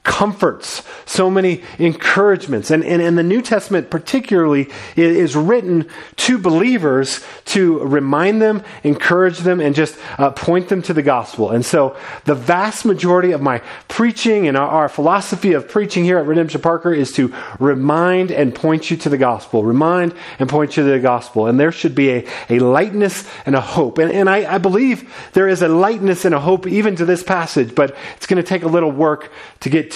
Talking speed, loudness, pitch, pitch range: 195 wpm, -15 LUFS, 170 Hz, 145-190 Hz